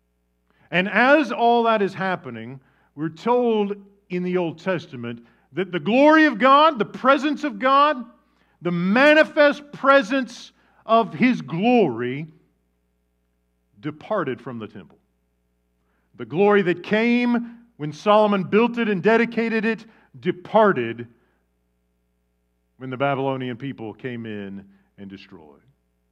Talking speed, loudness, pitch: 115 wpm, -20 LUFS, 180 Hz